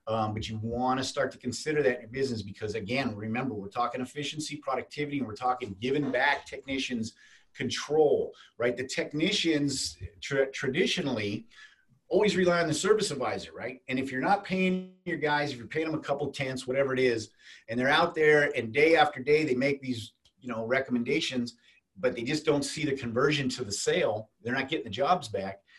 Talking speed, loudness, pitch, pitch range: 200 wpm, -29 LUFS, 135 Hz, 120-150 Hz